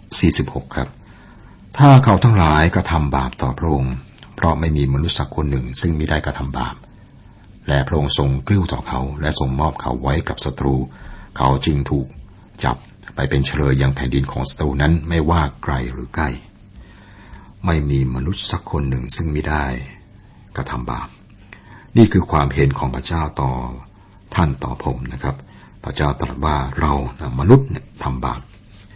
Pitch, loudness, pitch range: 75 Hz, -18 LUFS, 65-95 Hz